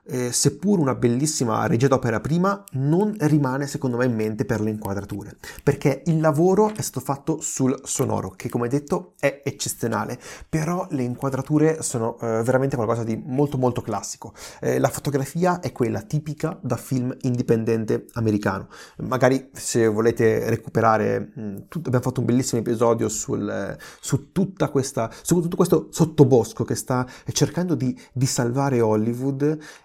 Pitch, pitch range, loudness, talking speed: 130 Hz, 115-150 Hz, -23 LUFS, 155 wpm